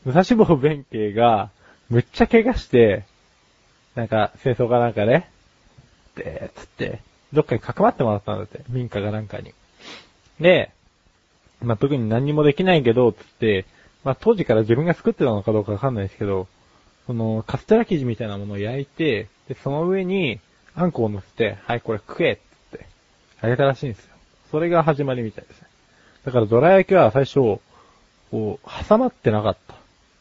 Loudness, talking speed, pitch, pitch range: -20 LUFS, 350 characters per minute, 120 Hz, 105-150 Hz